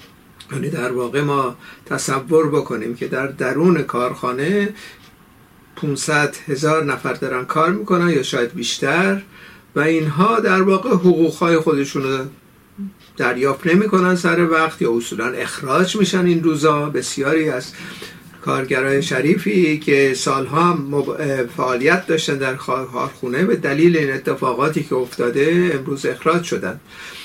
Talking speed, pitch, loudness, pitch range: 125 wpm, 155 Hz, -18 LUFS, 135-175 Hz